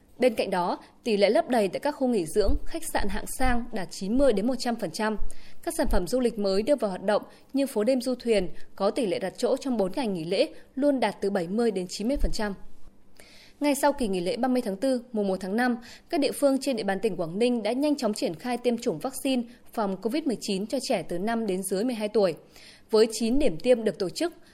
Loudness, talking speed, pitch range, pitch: -27 LUFS, 235 wpm, 205-260 Hz, 230 Hz